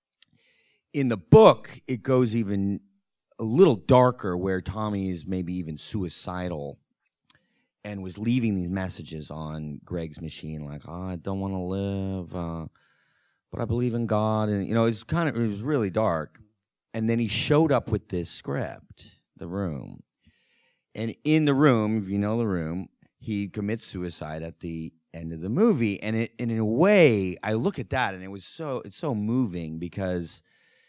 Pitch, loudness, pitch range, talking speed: 100 Hz, -26 LUFS, 90-115 Hz, 180 wpm